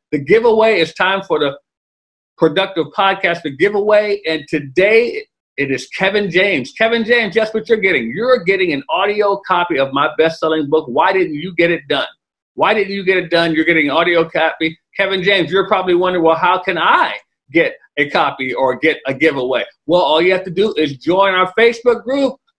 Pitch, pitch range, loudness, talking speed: 190 Hz, 160-220 Hz, -15 LUFS, 200 wpm